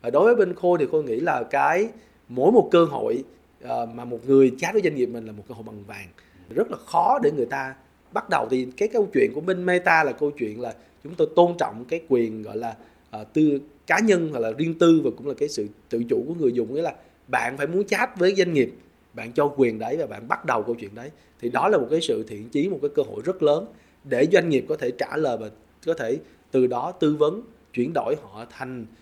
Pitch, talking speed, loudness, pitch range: 150 Hz, 260 wpm, -23 LUFS, 120-190 Hz